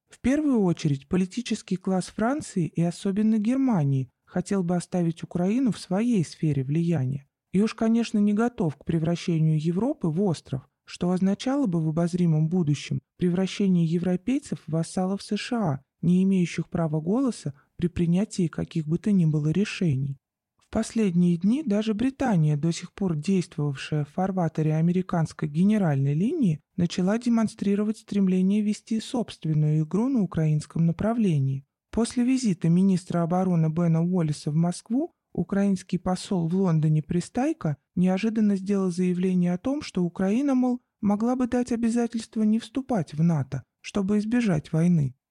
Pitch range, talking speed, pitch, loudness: 165-215 Hz, 140 wpm, 185 Hz, -25 LUFS